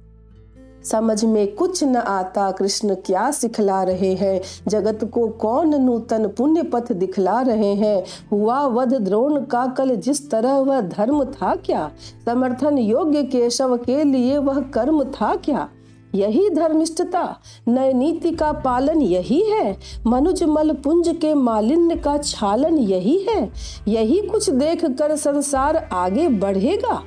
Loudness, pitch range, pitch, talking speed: -19 LUFS, 210-300 Hz, 255 Hz, 135 wpm